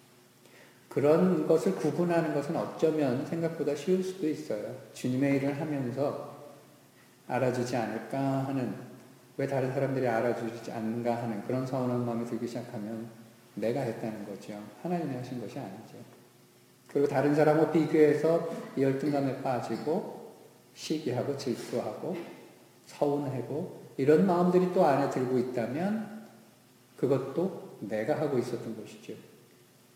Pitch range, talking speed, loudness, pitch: 120-150 Hz, 295 characters per minute, -30 LUFS, 130 Hz